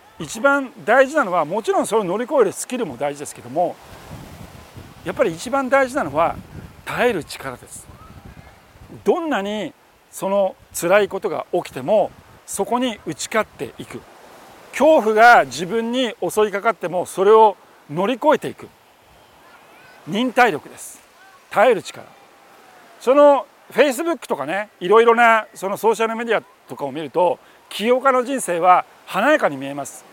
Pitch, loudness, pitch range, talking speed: 225 Hz, -18 LUFS, 190-265 Hz, 305 characters per minute